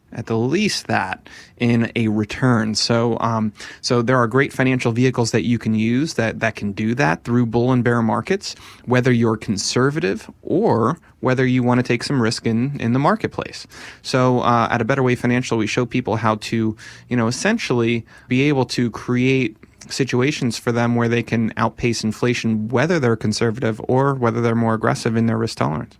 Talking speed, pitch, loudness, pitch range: 190 wpm, 120 Hz, -19 LUFS, 115-125 Hz